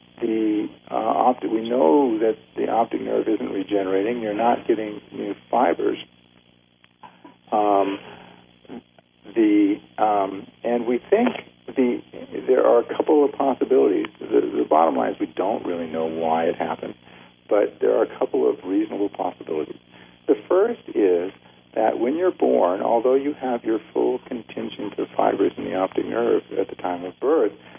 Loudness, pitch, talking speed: -22 LUFS, 105 Hz, 160 wpm